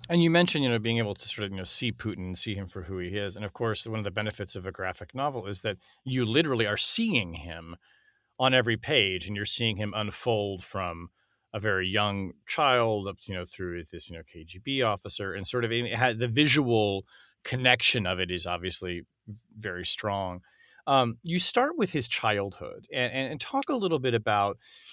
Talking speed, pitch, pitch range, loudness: 210 wpm, 105 Hz, 95-125 Hz, -27 LUFS